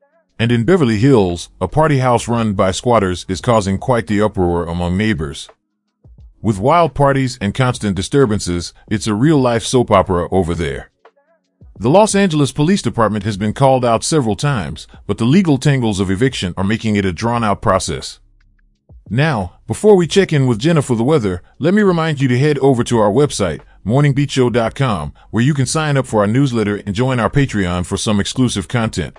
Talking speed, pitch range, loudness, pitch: 190 wpm, 100-135 Hz, -15 LUFS, 115 Hz